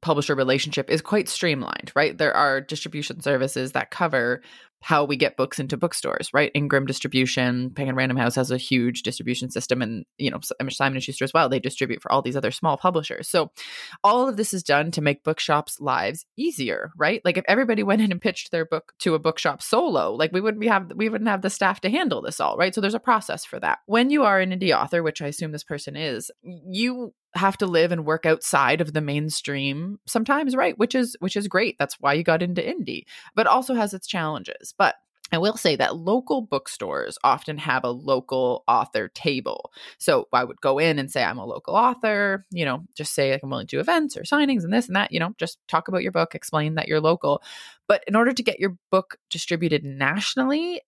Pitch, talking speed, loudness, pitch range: 165 Hz, 225 wpm, -23 LUFS, 140-210 Hz